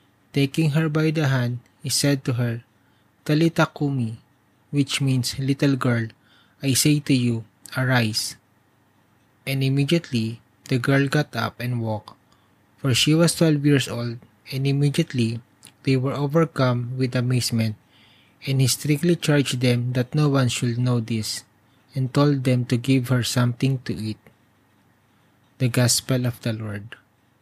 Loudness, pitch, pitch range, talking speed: -22 LUFS, 125 Hz, 115-140 Hz, 140 wpm